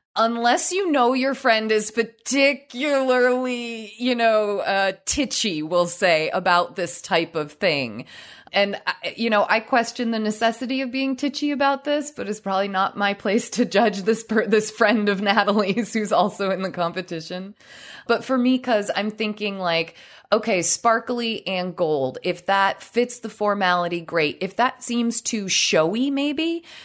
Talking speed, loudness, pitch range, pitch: 160 wpm, -22 LUFS, 195-245 Hz, 220 Hz